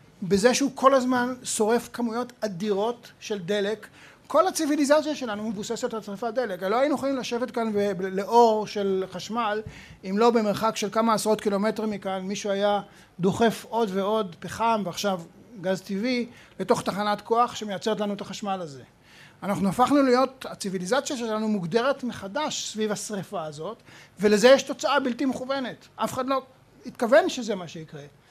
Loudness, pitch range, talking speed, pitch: -25 LUFS, 200-245 Hz, 155 wpm, 220 Hz